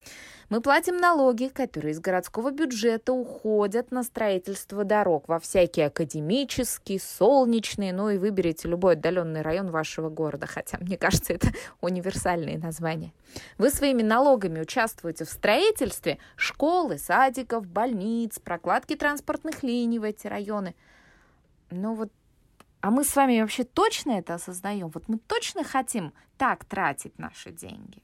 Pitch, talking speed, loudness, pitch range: 215 Hz, 135 wpm, -26 LUFS, 175-255 Hz